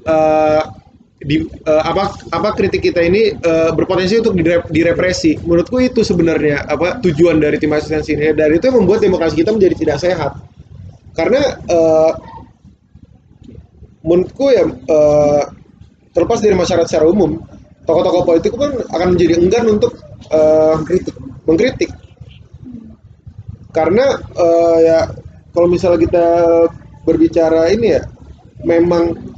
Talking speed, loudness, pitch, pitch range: 125 wpm, -13 LUFS, 165 Hz, 155-180 Hz